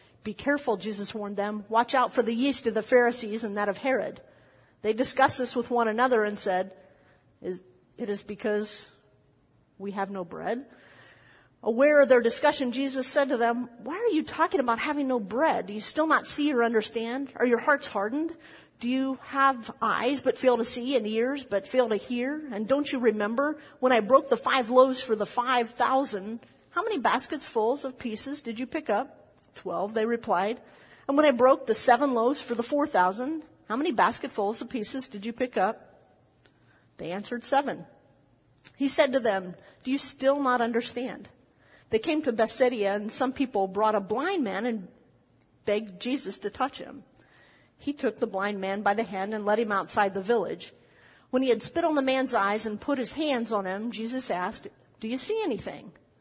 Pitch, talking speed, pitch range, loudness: 240 Hz, 195 wpm, 210-270 Hz, -27 LUFS